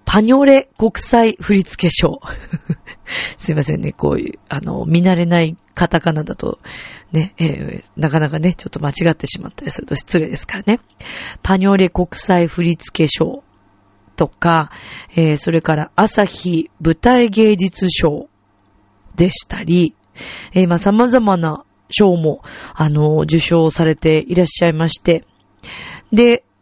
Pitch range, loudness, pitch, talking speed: 155-190 Hz, -15 LUFS, 170 Hz, 265 characters per minute